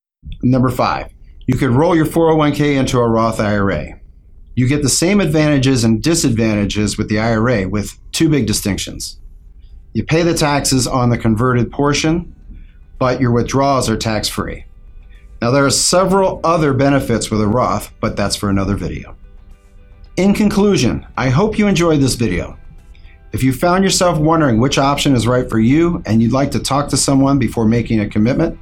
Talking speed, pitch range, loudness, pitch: 175 wpm, 100-145 Hz, -15 LUFS, 120 Hz